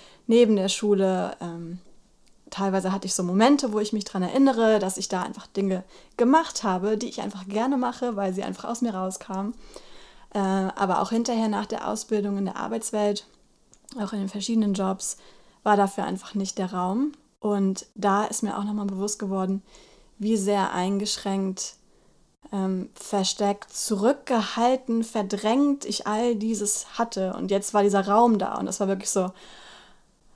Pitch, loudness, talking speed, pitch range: 205 Hz, -25 LUFS, 165 wpm, 195-225 Hz